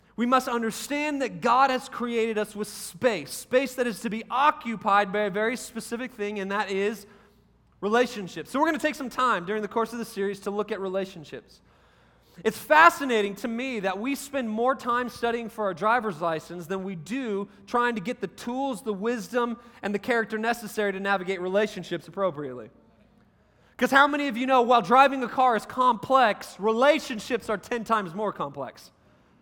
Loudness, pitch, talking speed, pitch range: -26 LUFS, 225 Hz, 190 wpm, 200-250 Hz